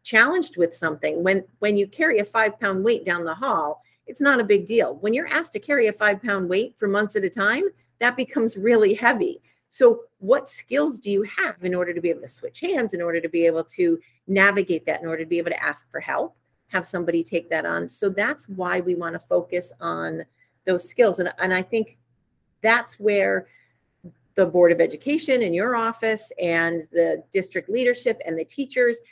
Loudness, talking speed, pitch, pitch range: -22 LUFS, 210 wpm, 200 Hz, 170-235 Hz